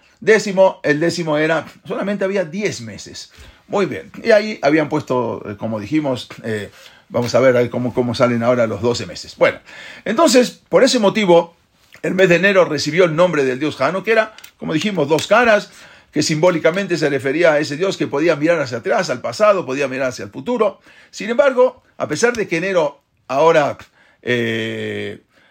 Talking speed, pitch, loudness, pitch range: 180 wpm, 160 Hz, -17 LUFS, 125-200 Hz